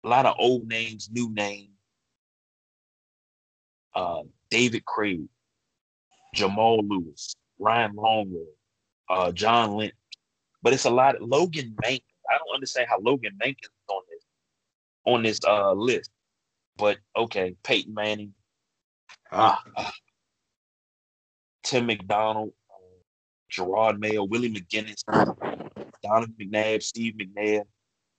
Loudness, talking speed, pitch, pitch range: -25 LUFS, 110 wpm, 110 Hz, 105-115 Hz